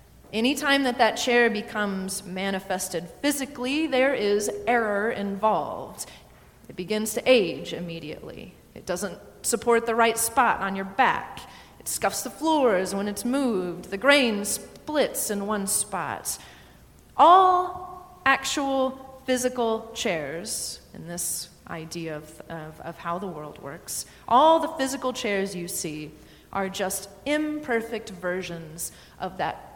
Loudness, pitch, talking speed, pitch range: -25 LUFS, 215 Hz, 130 wpm, 180-260 Hz